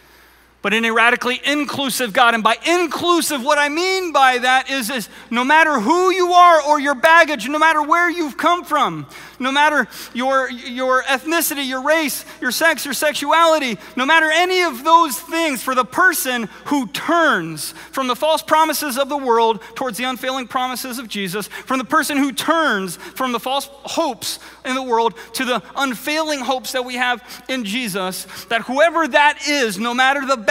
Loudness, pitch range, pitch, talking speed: -17 LUFS, 245-315 Hz, 270 Hz, 180 wpm